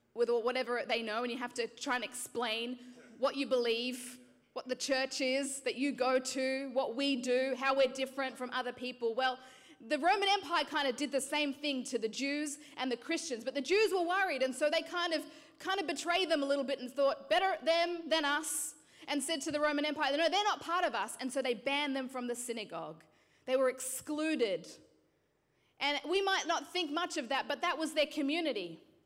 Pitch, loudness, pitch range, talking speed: 275 Hz, -34 LUFS, 255-315 Hz, 225 wpm